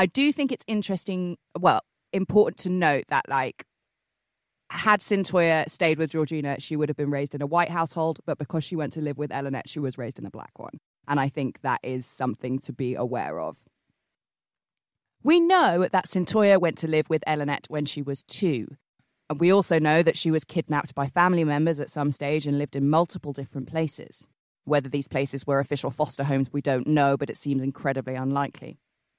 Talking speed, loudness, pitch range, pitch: 200 wpm, -25 LUFS, 140-170 Hz, 150 Hz